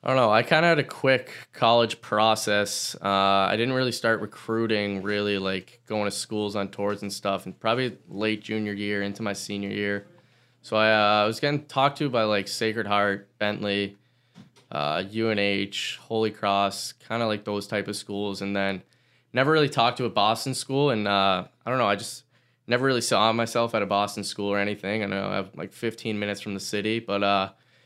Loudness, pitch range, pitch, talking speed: -25 LUFS, 100-115 Hz, 105 Hz, 210 wpm